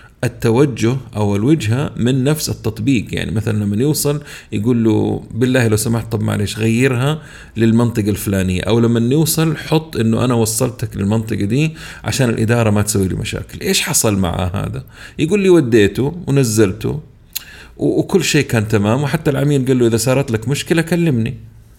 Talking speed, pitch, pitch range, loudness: 155 wpm, 120 Hz, 110-140 Hz, -16 LUFS